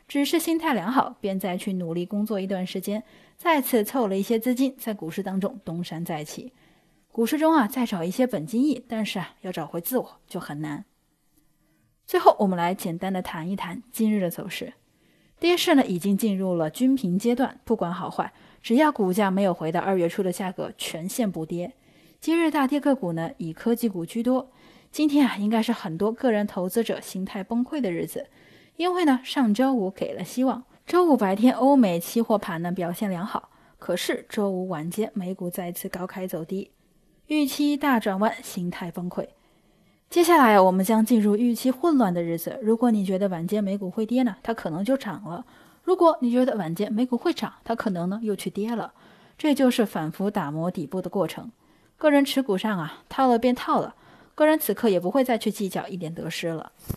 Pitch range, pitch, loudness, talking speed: 185-255 Hz, 210 Hz, -25 LUFS, 295 characters per minute